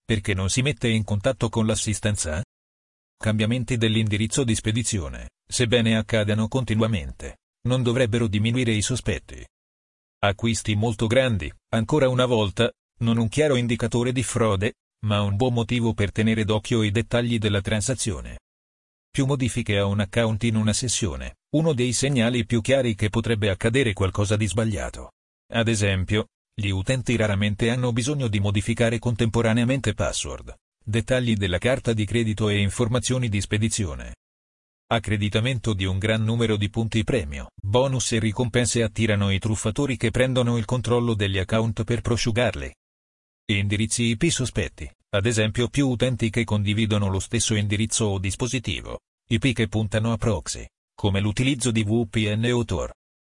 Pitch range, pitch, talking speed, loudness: 105-120 Hz, 110 Hz, 145 wpm, -23 LUFS